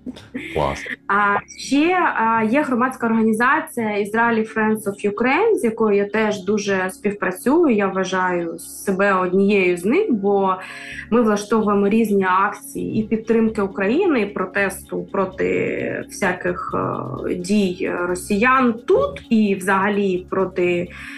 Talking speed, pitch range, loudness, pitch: 110 wpm, 195-230 Hz, -19 LUFS, 205 Hz